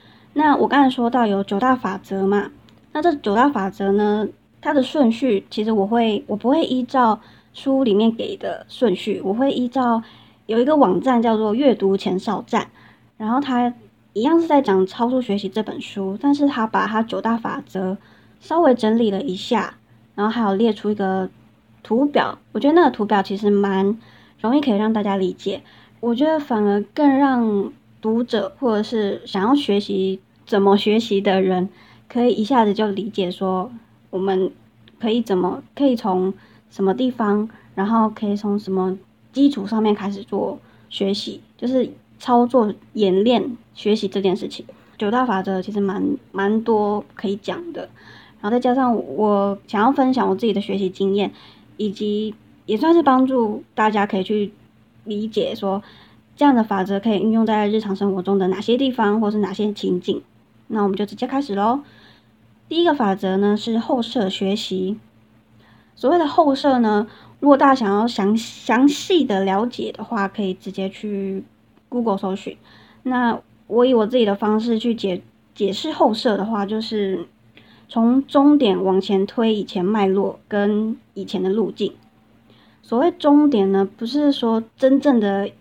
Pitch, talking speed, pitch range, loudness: 210 Hz, 250 characters per minute, 195-245 Hz, -20 LUFS